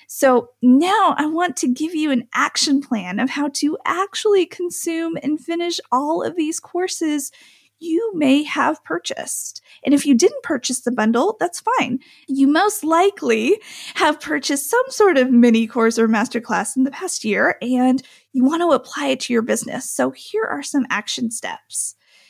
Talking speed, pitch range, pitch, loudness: 175 wpm, 255-350 Hz, 290 Hz, -19 LUFS